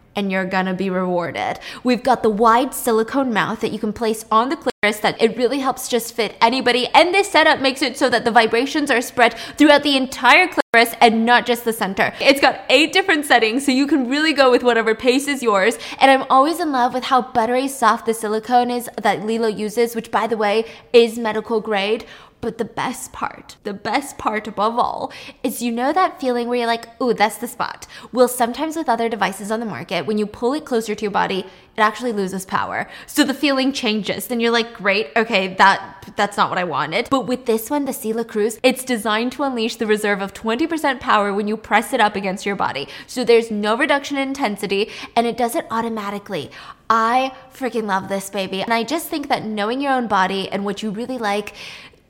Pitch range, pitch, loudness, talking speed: 215-260 Hz, 230 Hz, -18 LUFS, 220 wpm